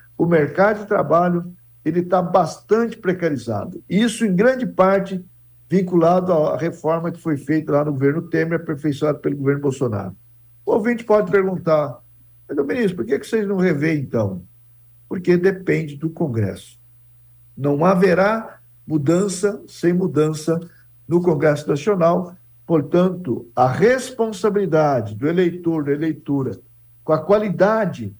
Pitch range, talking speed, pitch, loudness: 135-185 Hz, 130 wpm, 165 Hz, -19 LUFS